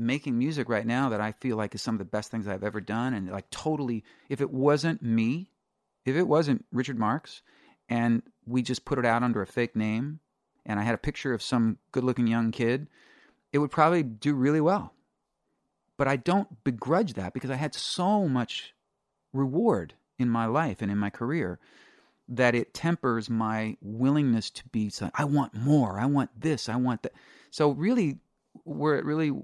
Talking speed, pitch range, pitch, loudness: 200 wpm, 115-145 Hz, 125 Hz, -28 LUFS